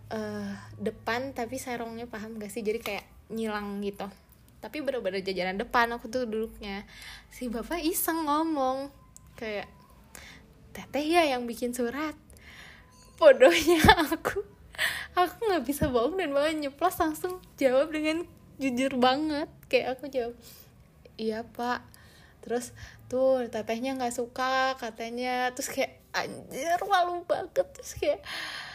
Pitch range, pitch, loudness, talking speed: 225-310 Hz, 255 Hz, -29 LUFS, 125 wpm